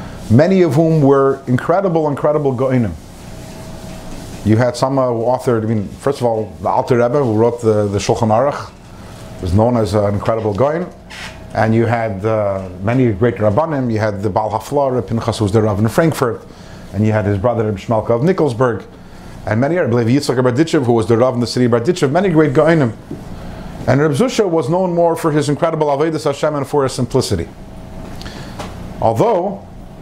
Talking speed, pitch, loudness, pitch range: 190 wpm, 120 Hz, -15 LUFS, 110-145 Hz